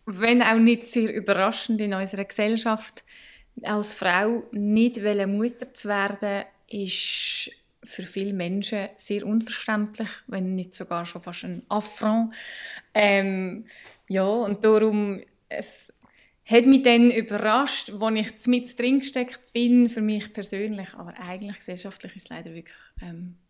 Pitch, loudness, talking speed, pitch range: 210 Hz, -24 LUFS, 135 wpm, 195-230 Hz